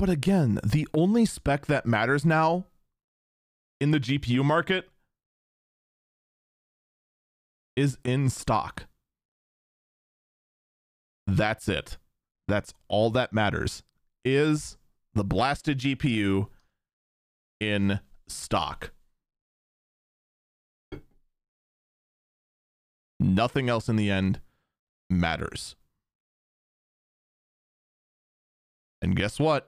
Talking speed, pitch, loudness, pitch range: 75 wpm, 120 Hz, -26 LUFS, 95-150 Hz